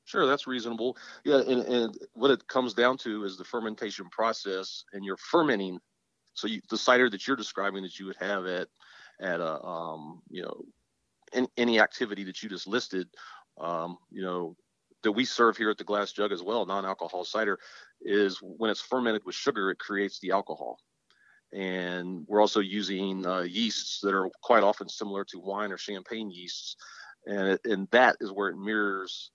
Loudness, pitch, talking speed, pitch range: -29 LUFS, 100 Hz, 185 wpm, 95-115 Hz